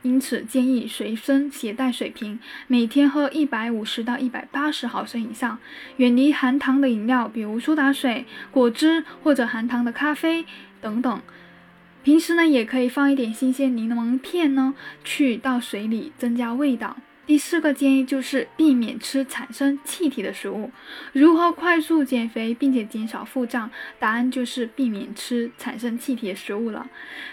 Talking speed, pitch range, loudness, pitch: 255 characters per minute, 235-285 Hz, -22 LUFS, 255 Hz